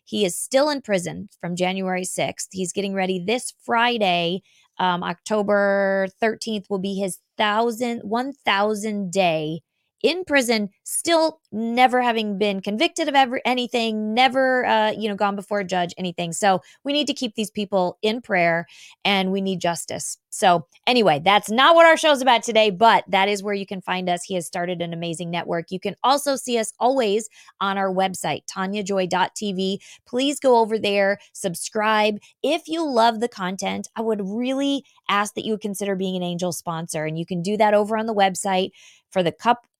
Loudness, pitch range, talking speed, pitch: -21 LUFS, 185-235 Hz, 180 wpm, 205 Hz